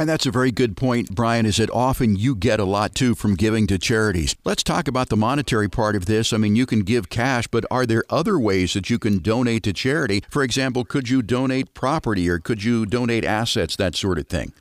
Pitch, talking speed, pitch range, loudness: 115 Hz, 240 wpm, 105-130 Hz, -21 LUFS